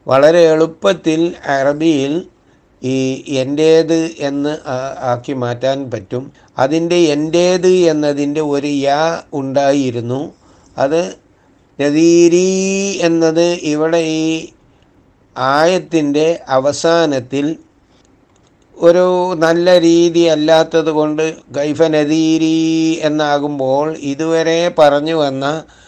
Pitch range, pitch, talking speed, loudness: 140-165 Hz, 155 Hz, 75 wpm, -14 LUFS